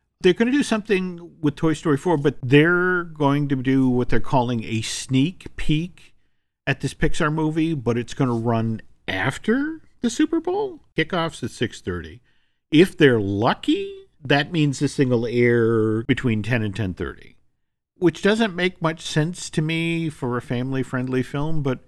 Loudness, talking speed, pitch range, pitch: -22 LUFS, 165 wpm, 125-170 Hz, 145 Hz